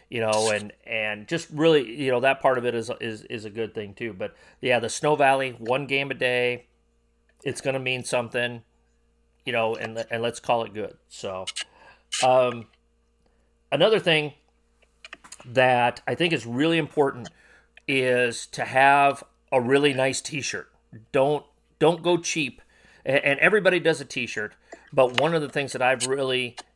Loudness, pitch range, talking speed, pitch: -24 LUFS, 115-140 Hz, 170 wpm, 125 Hz